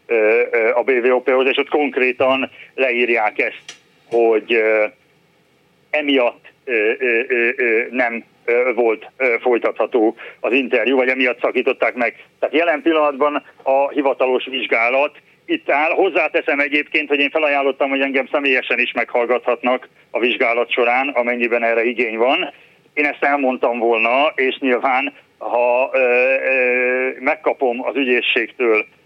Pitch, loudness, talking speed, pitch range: 135 Hz, -17 LUFS, 110 wpm, 125-150 Hz